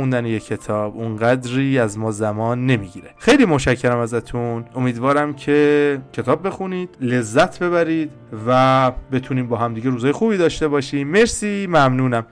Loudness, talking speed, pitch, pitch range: -18 LUFS, 130 wpm, 130 Hz, 120-145 Hz